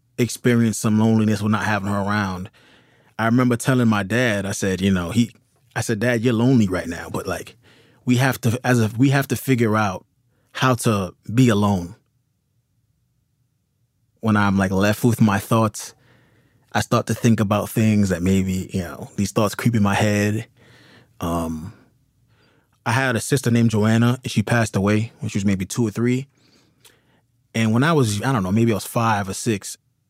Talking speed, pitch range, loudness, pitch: 190 wpm, 105-125 Hz, -20 LUFS, 115 Hz